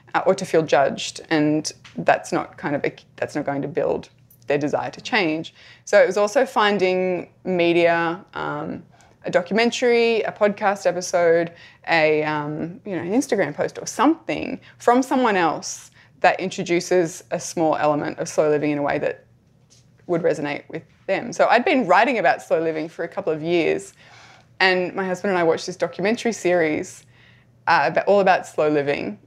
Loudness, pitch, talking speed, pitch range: -21 LUFS, 175 Hz, 175 wpm, 155-195 Hz